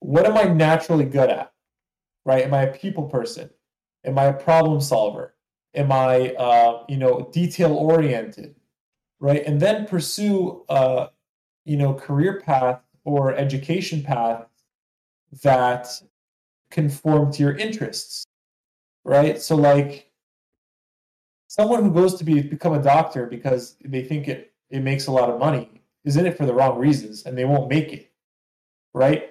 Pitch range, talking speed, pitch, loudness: 130-160 Hz, 155 wpm, 140 Hz, -20 LUFS